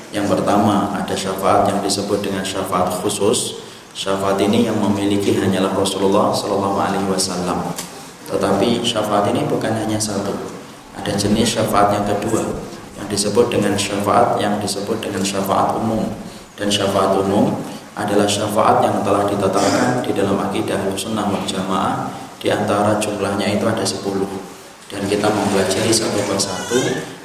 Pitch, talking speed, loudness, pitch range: 100 Hz, 140 wpm, -18 LUFS, 95-105 Hz